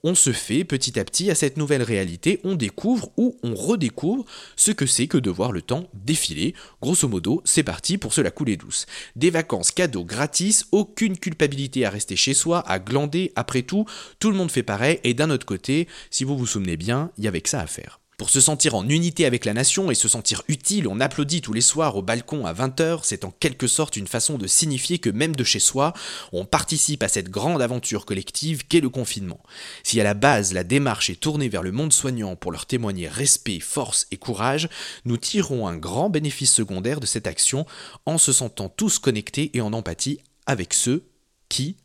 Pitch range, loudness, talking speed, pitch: 115-160 Hz, -21 LUFS, 215 wpm, 135 Hz